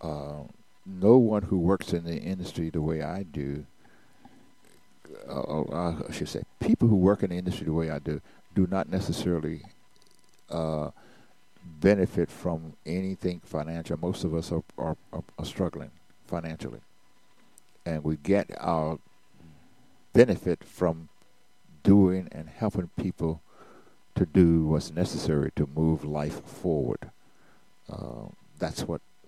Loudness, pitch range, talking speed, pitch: -28 LUFS, 75-95 Hz, 130 wpm, 80 Hz